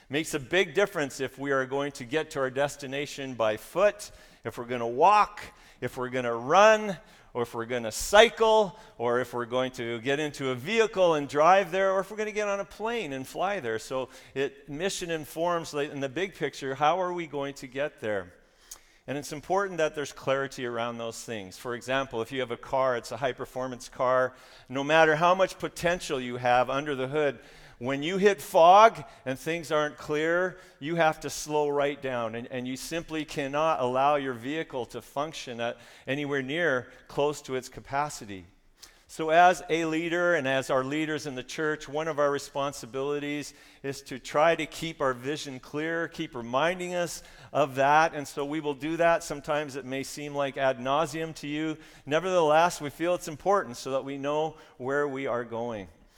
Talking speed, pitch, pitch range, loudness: 200 wpm, 145 Hz, 130-160 Hz, -28 LUFS